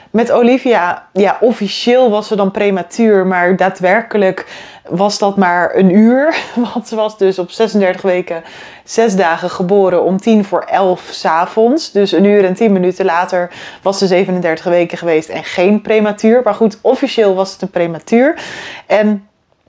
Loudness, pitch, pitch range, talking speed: -12 LUFS, 200 Hz, 180-220 Hz, 160 wpm